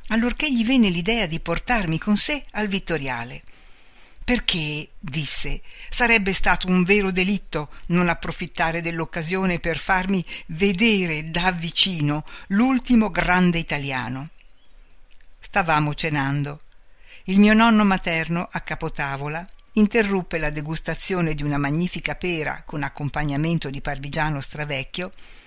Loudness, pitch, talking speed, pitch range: -22 LUFS, 170 Hz, 115 wpm, 150-195 Hz